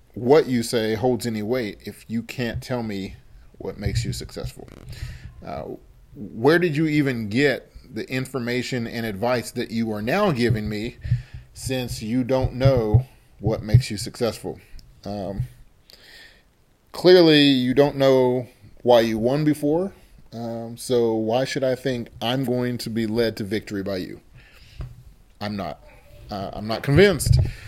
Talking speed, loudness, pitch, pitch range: 150 wpm, -22 LUFS, 120 Hz, 110-130 Hz